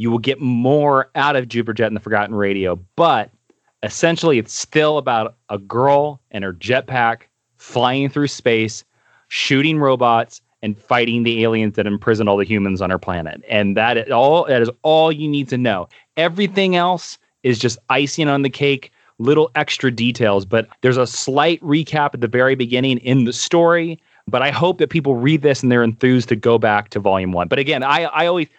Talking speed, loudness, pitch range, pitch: 195 wpm, -17 LUFS, 115-145 Hz, 125 Hz